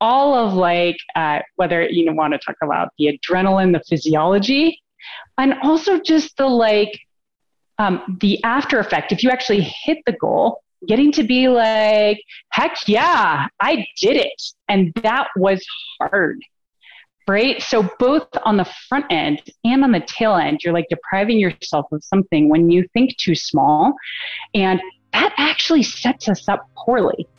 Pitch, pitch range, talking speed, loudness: 215 Hz, 185-265 Hz, 160 wpm, -17 LUFS